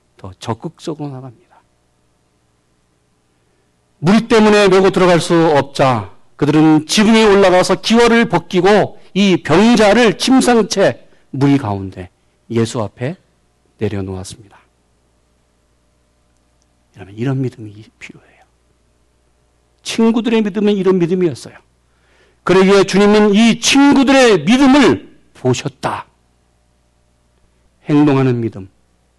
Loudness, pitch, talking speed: -12 LUFS, 120 Hz, 230 characters per minute